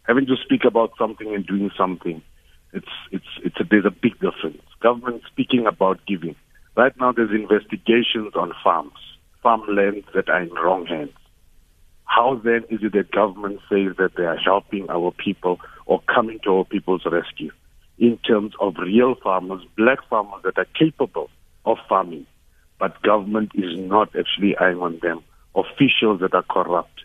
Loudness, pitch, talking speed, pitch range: -21 LUFS, 100 Hz, 170 wpm, 90-115 Hz